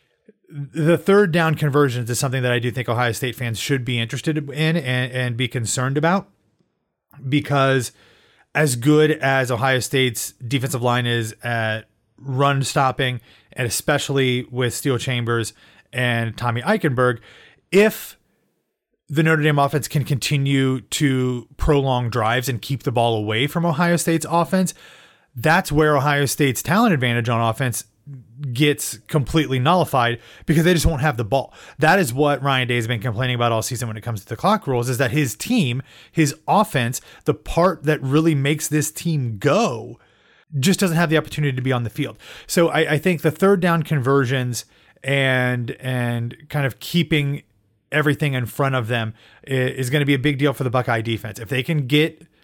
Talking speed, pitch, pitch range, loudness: 175 wpm, 135 Hz, 125-155 Hz, -20 LUFS